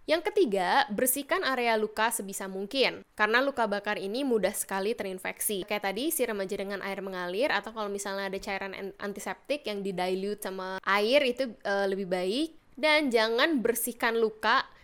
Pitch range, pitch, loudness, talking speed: 195-245 Hz, 210 Hz, -29 LUFS, 160 wpm